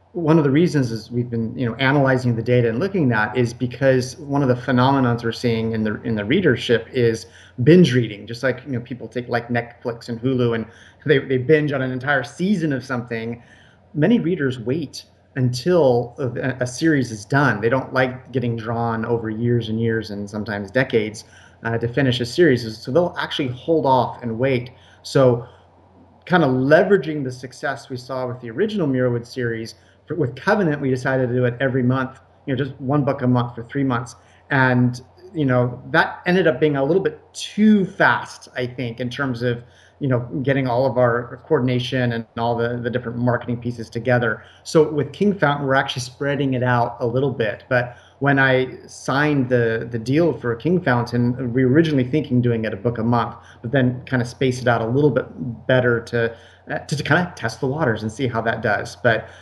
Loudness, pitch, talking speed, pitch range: -20 LUFS, 125 Hz, 205 wpm, 115-135 Hz